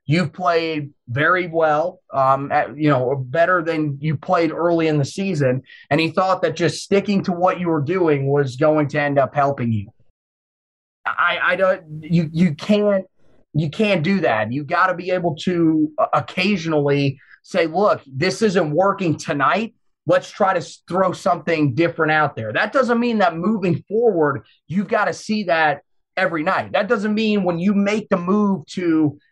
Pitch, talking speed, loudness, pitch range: 170 Hz, 180 wpm, -19 LUFS, 150-190 Hz